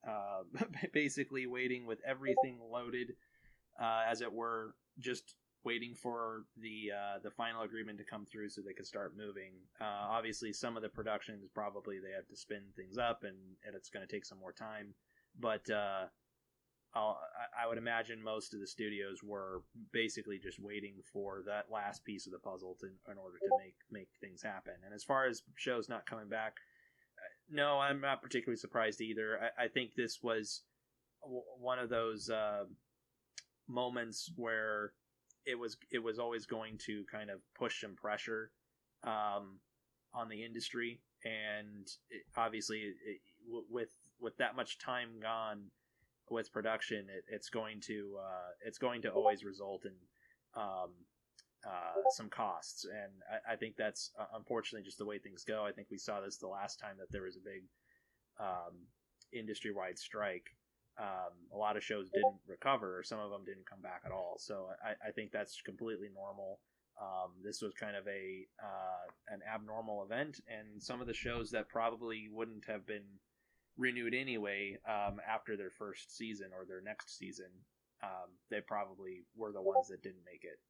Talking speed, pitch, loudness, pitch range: 175 wpm, 110 Hz, -42 LUFS, 100-120 Hz